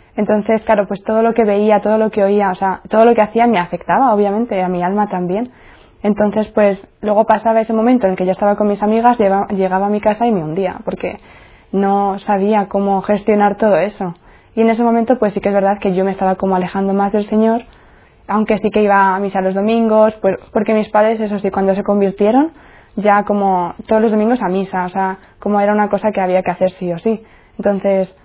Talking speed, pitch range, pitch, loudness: 230 wpm, 195-220 Hz, 205 Hz, -15 LUFS